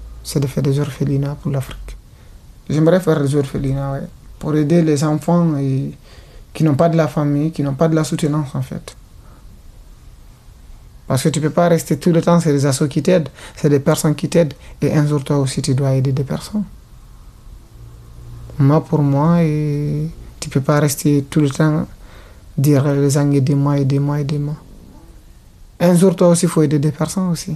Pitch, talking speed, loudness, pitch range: 150 Hz, 200 wpm, -17 LUFS, 140-160 Hz